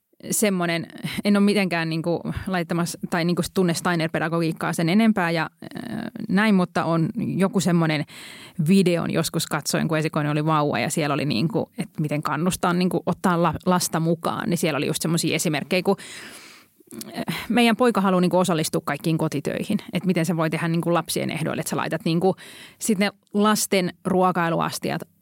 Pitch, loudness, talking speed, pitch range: 175 Hz, -23 LUFS, 155 wpm, 165-195 Hz